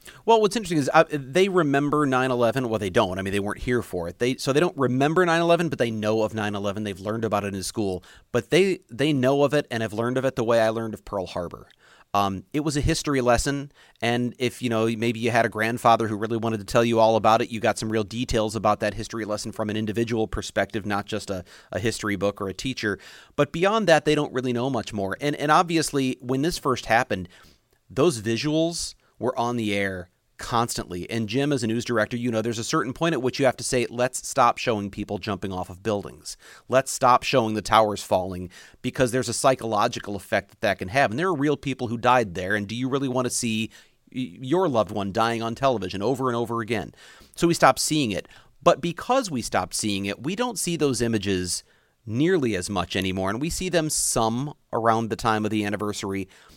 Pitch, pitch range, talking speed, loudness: 115 Hz, 105-135 Hz, 230 wpm, -24 LUFS